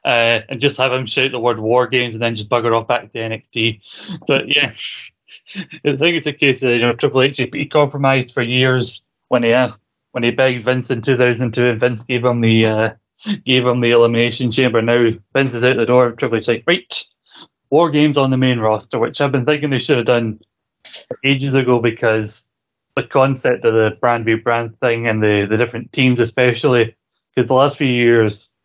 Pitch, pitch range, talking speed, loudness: 125 Hz, 115-130 Hz, 210 wpm, -16 LUFS